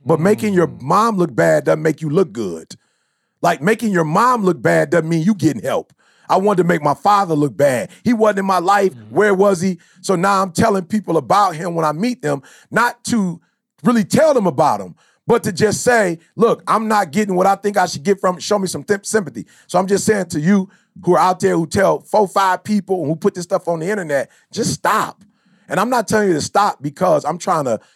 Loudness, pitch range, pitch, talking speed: -17 LUFS, 170-210 Hz, 195 Hz, 245 wpm